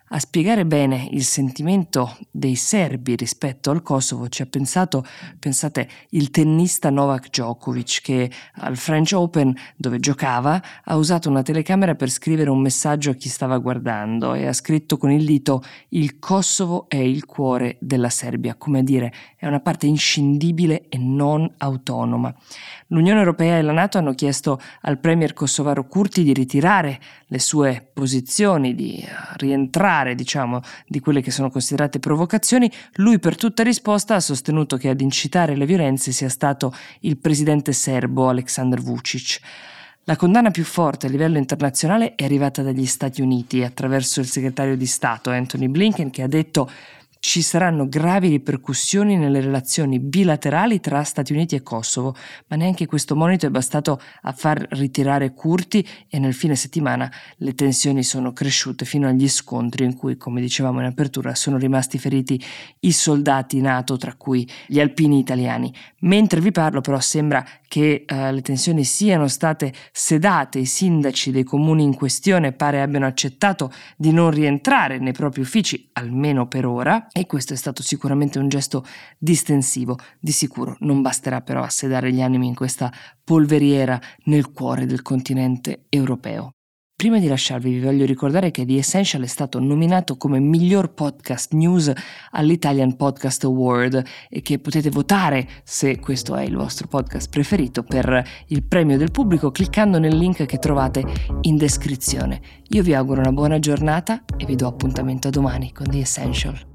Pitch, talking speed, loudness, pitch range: 140 Hz, 160 wpm, -19 LUFS, 130-155 Hz